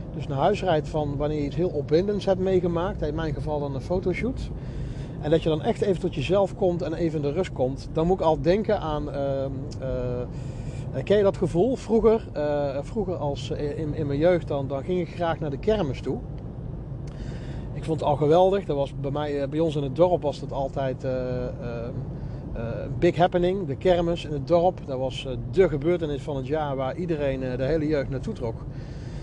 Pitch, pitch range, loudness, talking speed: 150 Hz, 135-175 Hz, -26 LUFS, 205 wpm